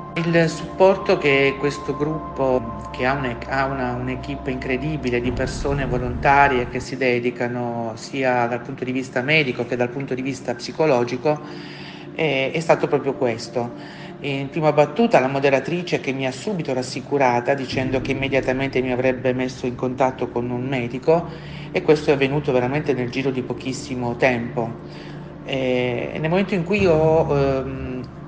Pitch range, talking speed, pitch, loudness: 125-150 Hz, 150 wpm, 135 Hz, -21 LUFS